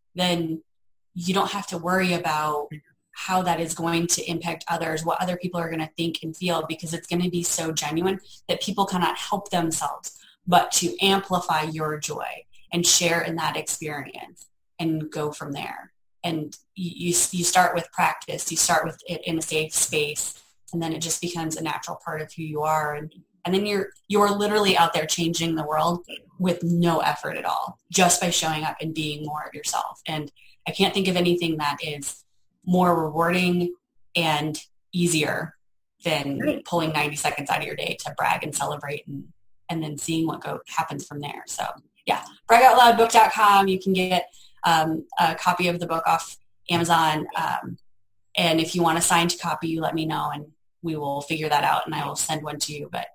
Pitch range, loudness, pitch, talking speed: 155-175 Hz, -23 LUFS, 165 Hz, 200 wpm